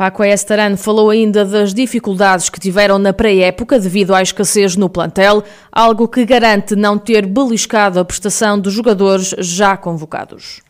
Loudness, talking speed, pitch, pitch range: -12 LUFS, 150 wpm, 205 Hz, 195-215 Hz